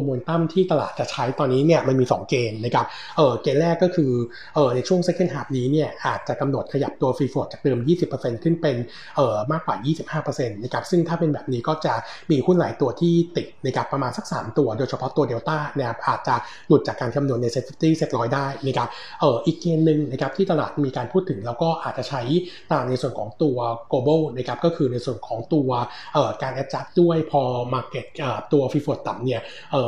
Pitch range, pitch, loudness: 125-160 Hz, 145 Hz, -23 LUFS